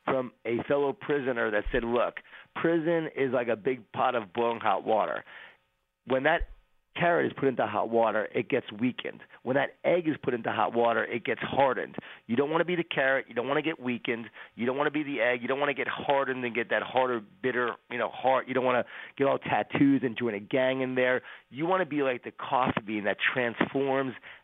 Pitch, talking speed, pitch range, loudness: 130 Hz, 235 wpm, 115-140 Hz, -28 LUFS